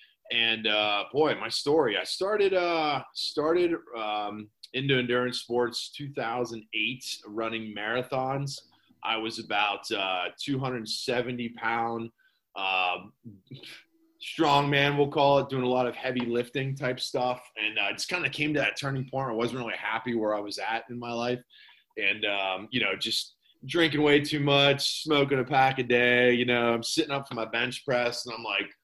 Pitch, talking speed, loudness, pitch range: 125 Hz, 175 wpm, -27 LUFS, 115-140 Hz